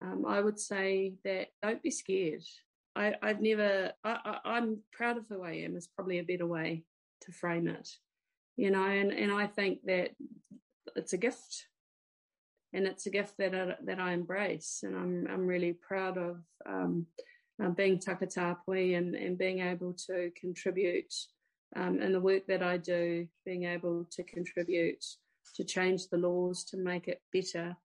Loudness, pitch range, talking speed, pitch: -34 LUFS, 175-205 Hz, 175 wpm, 185 Hz